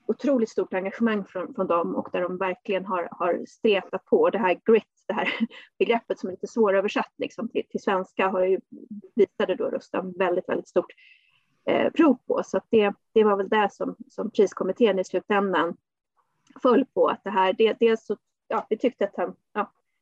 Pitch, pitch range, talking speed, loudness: 205 Hz, 190-230 Hz, 190 wpm, -25 LUFS